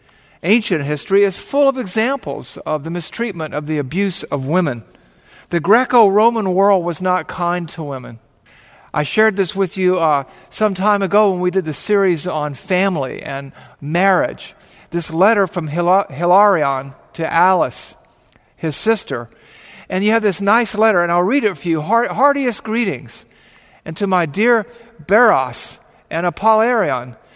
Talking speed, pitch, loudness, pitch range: 155 wpm, 185 Hz, -17 LUFS, 160-210 Hz